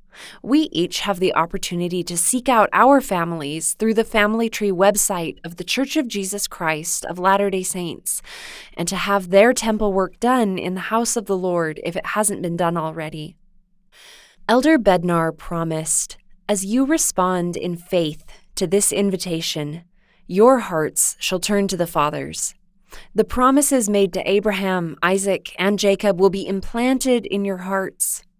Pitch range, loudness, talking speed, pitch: 175-210 Hz, -19 LUFS, 160 wpm, 195 Hz